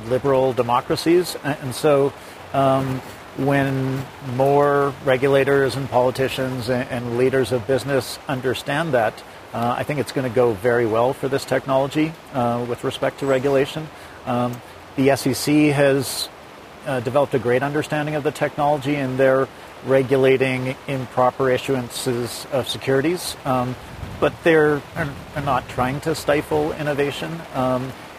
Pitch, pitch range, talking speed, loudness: 135 Hz, 125-140 Hz, 135 wpm, -21 LUFS